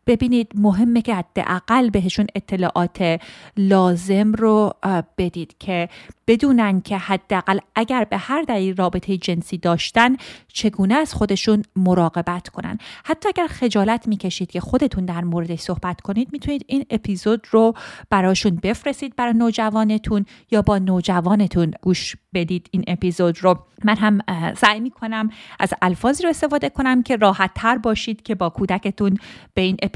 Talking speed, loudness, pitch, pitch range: 140 wpm, -20 LUFS, 200 Hz, 185-230 Hz